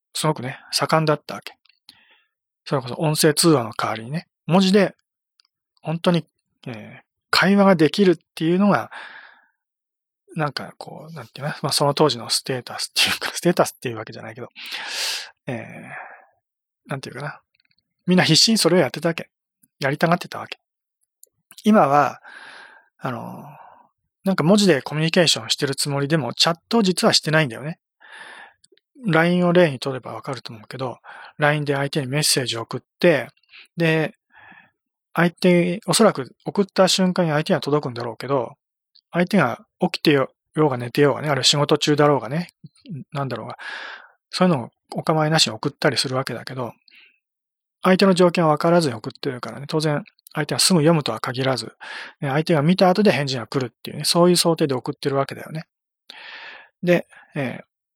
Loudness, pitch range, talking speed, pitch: -20 LUFS, 140-185 Hz, 355 characters per minute, 160 Hz